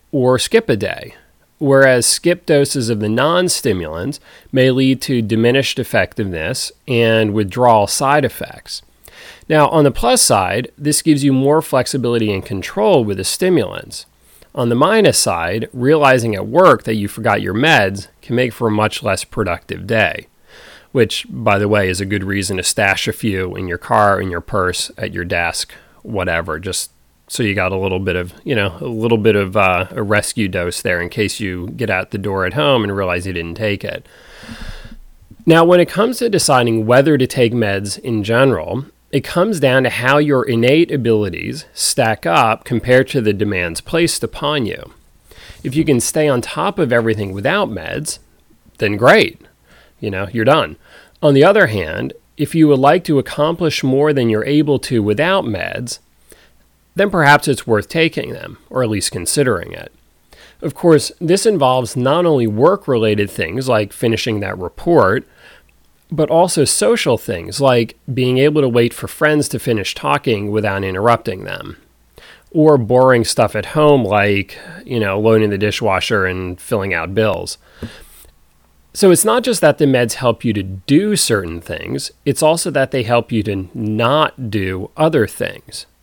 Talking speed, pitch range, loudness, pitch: 175 wpm, 100-145 Hz, -15 LUFS, 115 Hz